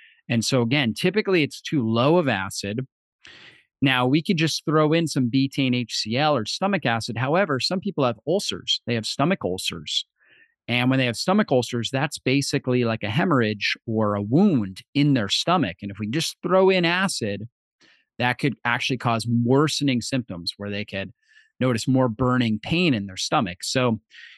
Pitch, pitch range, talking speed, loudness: 130 Hz, 115-155 Hz, 175 wpm, -23 LUFS